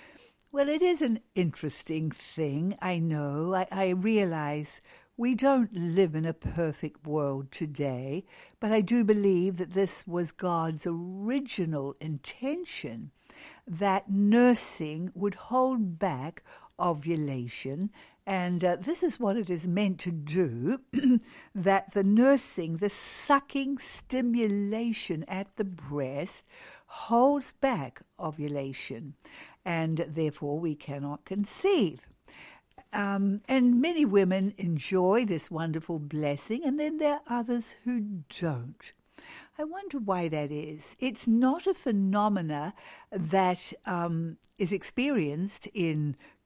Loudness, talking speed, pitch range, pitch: -29 LUFS, 120 wpm, 160-235 Hz, 190 Hz